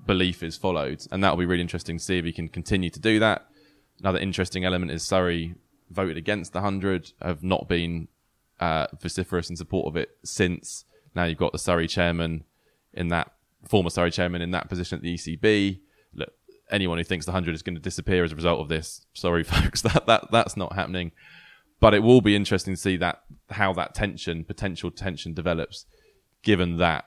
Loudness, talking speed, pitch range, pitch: -25 LUFS, 200 wpm, 85-95 Hz, 90 Hz